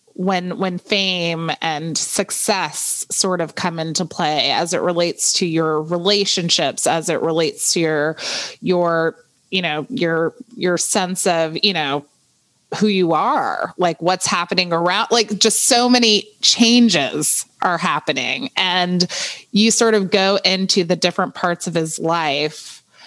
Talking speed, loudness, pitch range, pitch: 145 wpm, -17 LUFS, 170-210 Hz, 180 Hz